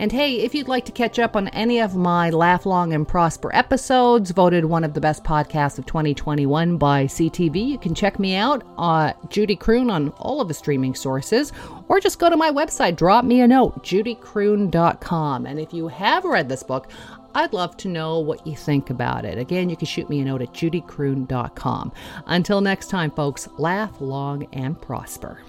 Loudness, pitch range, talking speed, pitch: -21 LUFS, 150-215 Hz, 200 wpm, 170 Hz